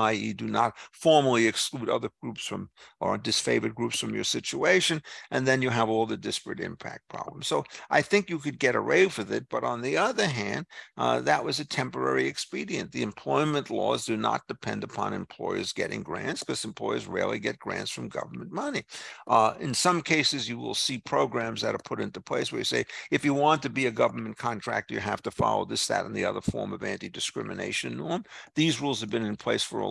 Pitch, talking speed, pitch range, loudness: 130 Hz, 215 wpm, 110-150 Hz, -28 LUFS